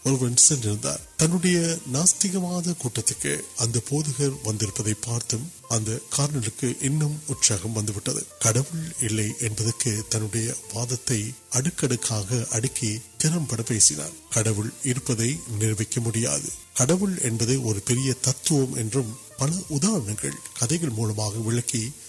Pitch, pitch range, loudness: 120 Hz, 110-140 Hz, -24 LUFS